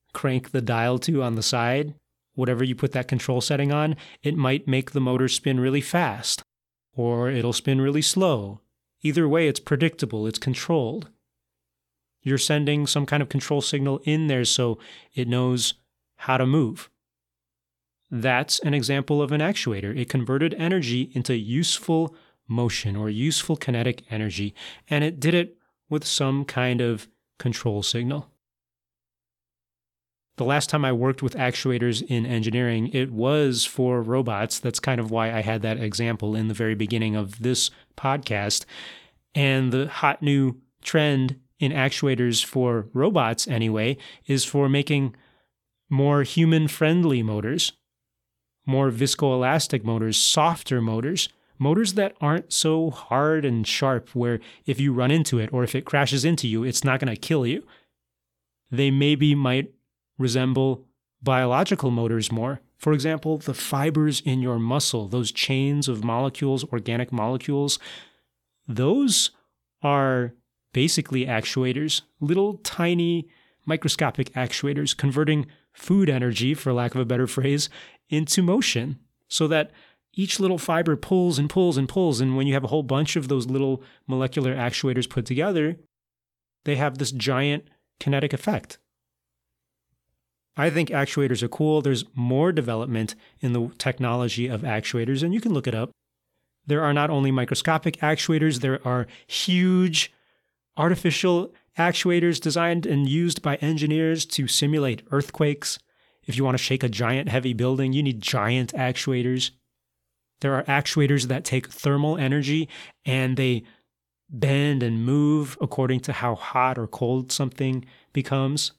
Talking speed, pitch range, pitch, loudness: 145 wpm, 120-150 Hz, 130 Hz, -24 LUFS